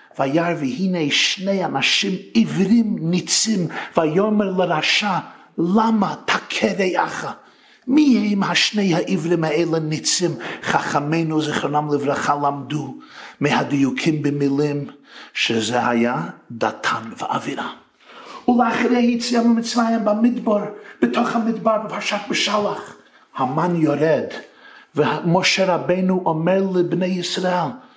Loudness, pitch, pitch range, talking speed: -19 LUFS, 185 Hz, 155-220 Hz, 90 wpm